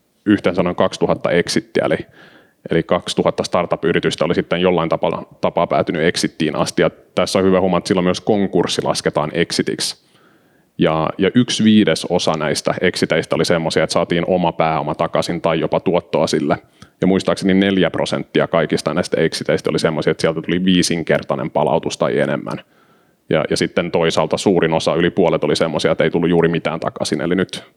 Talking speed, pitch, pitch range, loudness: 160 wpm, 85 Hz, 80-95 Hz, -17 LUFS